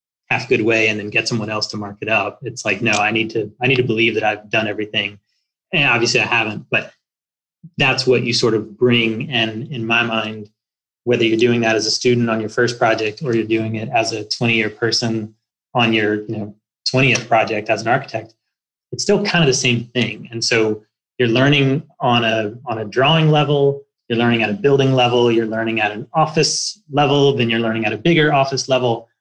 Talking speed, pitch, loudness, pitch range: 220 wpm, 115 Hz, -17 LUFS, 110-130 Hz